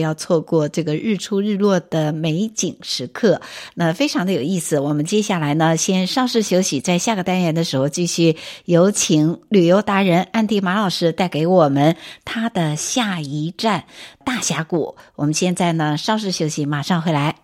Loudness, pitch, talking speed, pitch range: -18 LUFS, 175 Hz, 270 characters per minute, 155-195 Hz